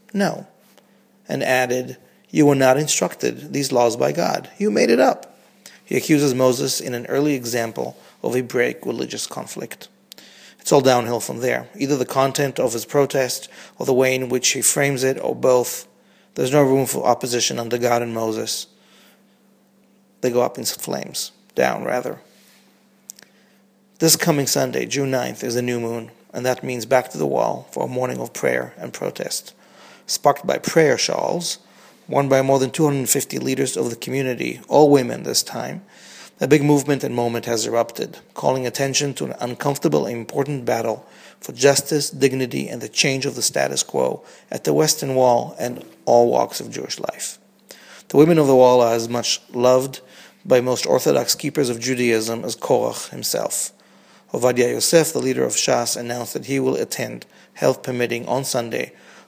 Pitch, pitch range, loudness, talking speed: 130 Hz, 120-140 Hz, -20 LUFS, 175 wpm